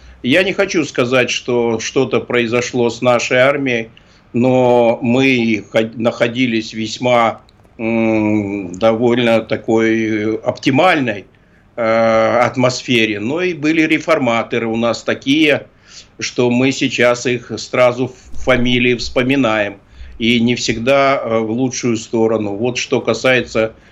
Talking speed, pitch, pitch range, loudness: 110 wpm, 120 Hz, 110-125 Hz, -15 LUFS